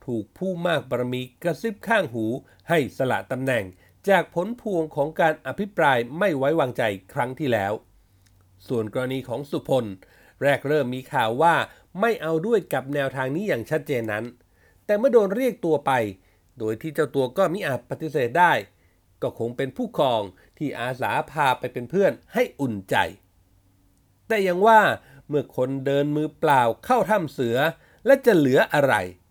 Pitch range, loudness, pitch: 110-170 Hz, -23 LUFS, 135 Hz